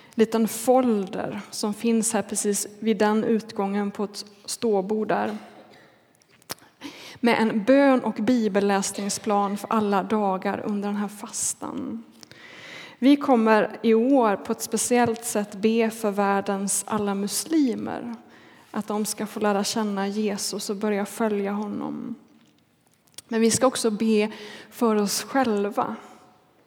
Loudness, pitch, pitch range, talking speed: -24 LUFS, 215 Hz, 205-230 Hz, 130 wpm